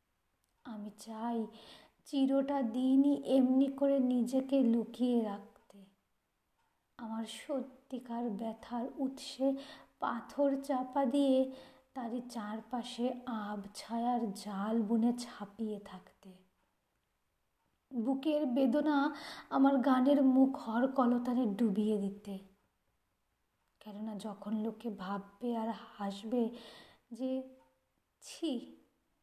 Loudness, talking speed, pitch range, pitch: -34 LUFS, 80 wpm, 215-265 Hz, 240 Hz